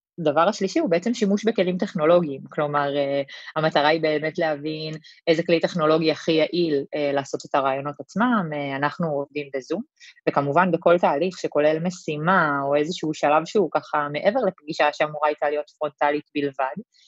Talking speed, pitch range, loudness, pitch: 145 wpm, 145-175 Hz, -23 LUFS, 155 Hz